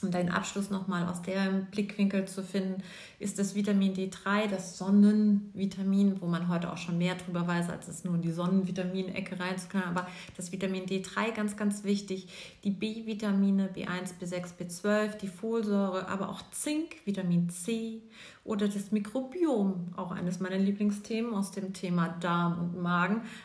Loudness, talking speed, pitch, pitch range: -31 LUFS, 160 wpm, 195 Hz, 180-205 Hz